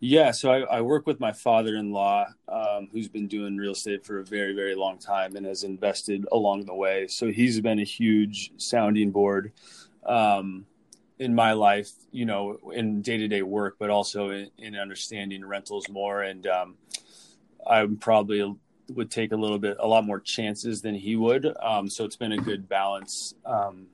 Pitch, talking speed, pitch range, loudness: 100 Hz, 195 wpm, 100-110 Hz, -26 LUFS